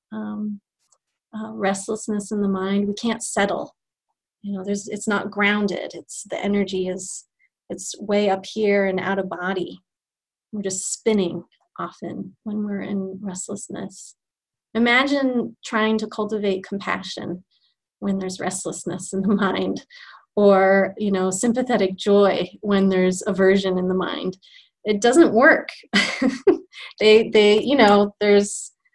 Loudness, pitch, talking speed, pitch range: -21 LUFS, 205 Hz, 135 wpm, 190-215 Hz